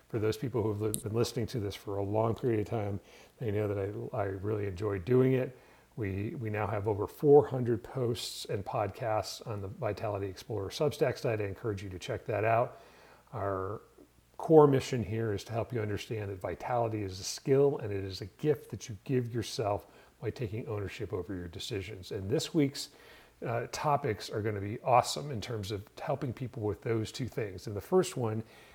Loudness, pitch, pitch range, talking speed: -33 LUFS, 110 Hz, 100-125 Hz, 205 wpm